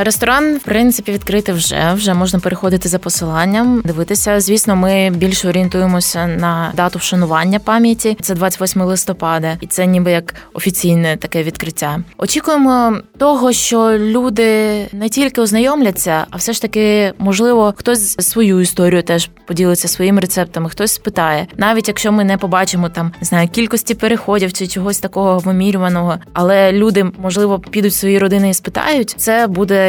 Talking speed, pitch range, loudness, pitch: 150 wpm, 180-215 Hz, -13 LUFS, 195 Hz